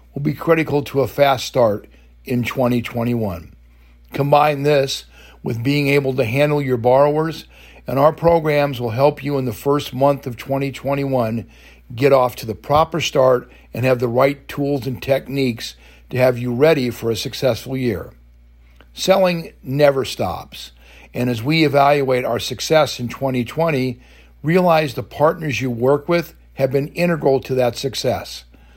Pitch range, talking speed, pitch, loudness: 115-145 Hz, 155 wpm, 130 Hz, -18 LUFS